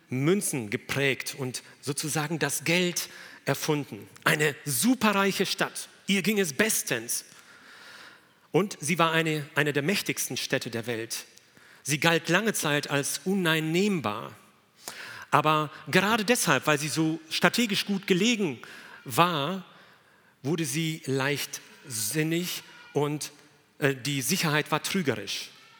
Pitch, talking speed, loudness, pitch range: 155 Hz, 115 wpm, -27 LUFS, 140-180 Hz